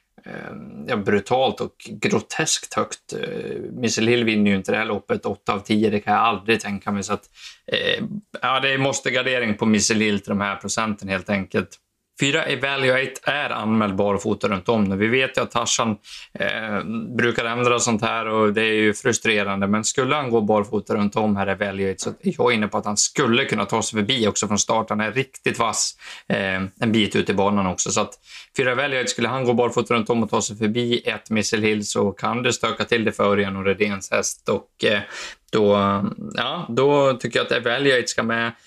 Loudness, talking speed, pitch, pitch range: -21 LUFS, 205 wpm, 110 Hz, 100-120 Hz